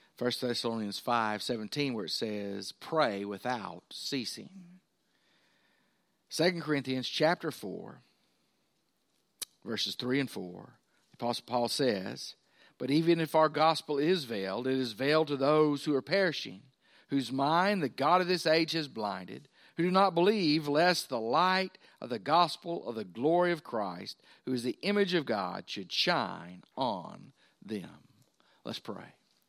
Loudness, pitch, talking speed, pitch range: -31 LUFS, 145 Hz, 145 wpm, 120-170 Hz